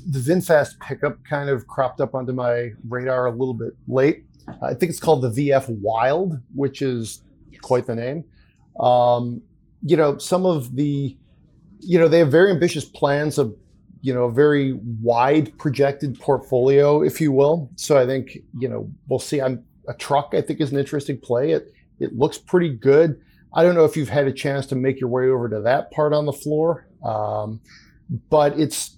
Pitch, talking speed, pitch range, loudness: 140 Hz, 195 wpm, 125-150 Hz, -20 LUFS